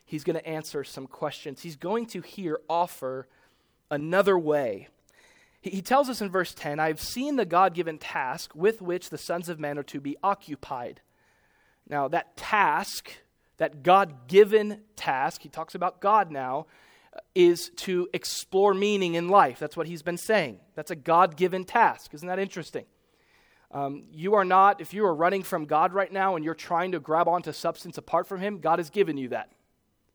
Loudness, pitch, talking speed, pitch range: -26 LUFS, 175 Hz, 180 wpm, 155-200 Hz